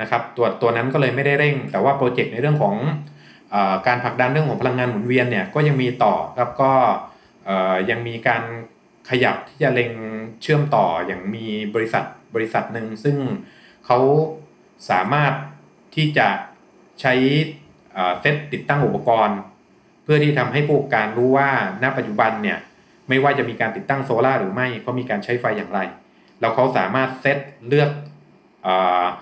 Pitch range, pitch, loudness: 115-145 Hz, 125 Hz, -20 LUFS